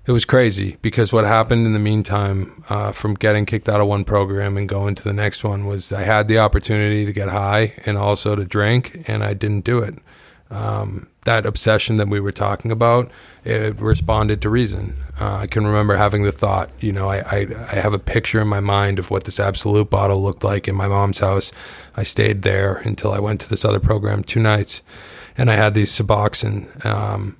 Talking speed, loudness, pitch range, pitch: 215 wpm, -19 LUFS, 100-110 Hz, 105 Hz